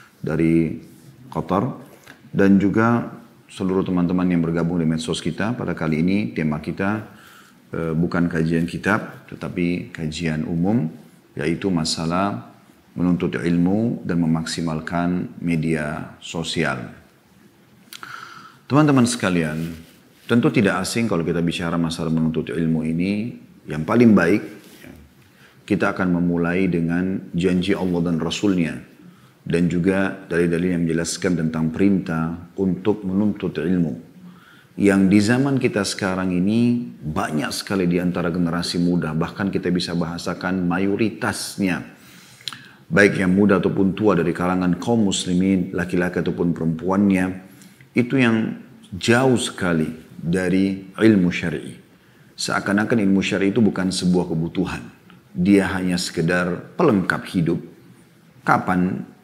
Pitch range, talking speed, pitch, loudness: 85-95 Hz, 115 wpm, 90 Hz, -21 LUFS